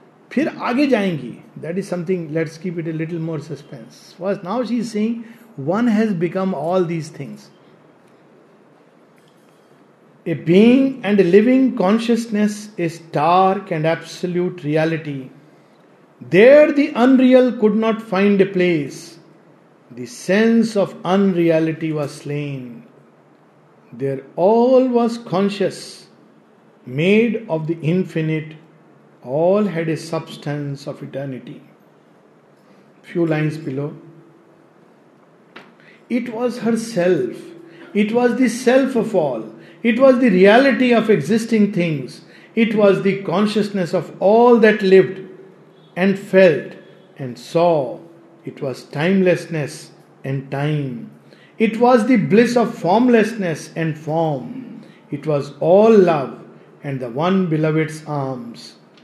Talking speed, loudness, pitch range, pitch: 115 wpm, -17 LUFS, 160-220 Hz, 180 Hz